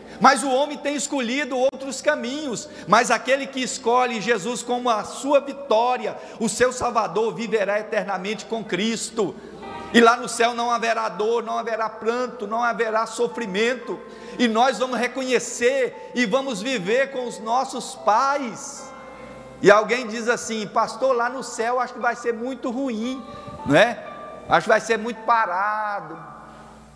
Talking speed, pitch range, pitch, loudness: 155 wpm, 225-260 Hz, 235 Hz, -22 LUFS